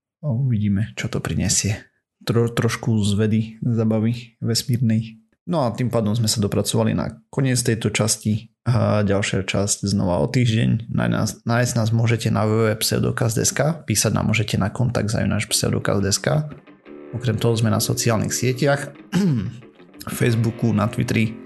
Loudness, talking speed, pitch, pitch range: -21 LUFS, 135 wpm, 115 Hz, 105-120 Hz